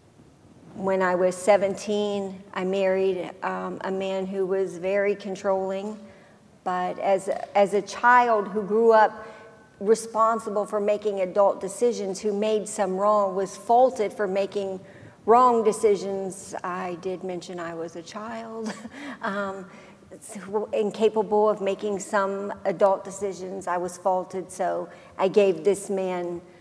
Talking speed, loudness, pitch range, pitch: 135 wpm, -25 LUFS, 190-210 Hz, 195 Hz